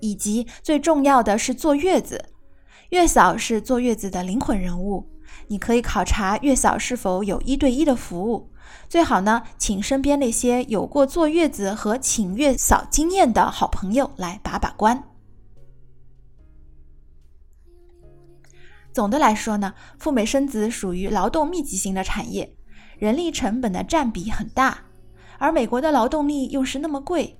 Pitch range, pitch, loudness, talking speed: 190-275 Hz, 225 Hz, -21 LUFS, 230 characters per minute